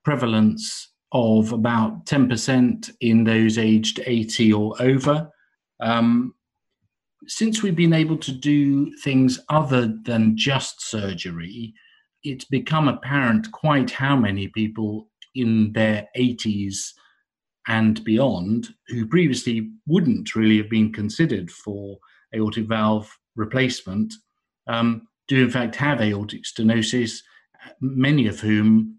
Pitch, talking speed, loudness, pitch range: 115 Hz, 115 wpm, -21 LUFS, 110-140 Hz